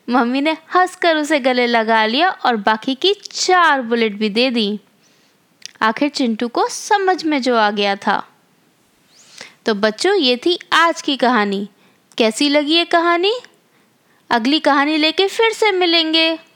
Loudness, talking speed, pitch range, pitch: -16 LUFS, 150 wpm, 230-345 Hz, 290 Hz